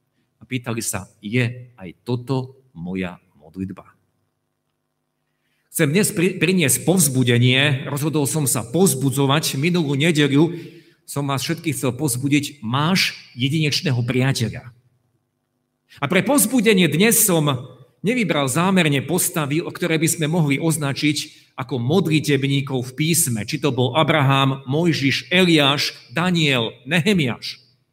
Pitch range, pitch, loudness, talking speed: 125-160 Hz, 140 Hz, -19 LUFS, 110 wpm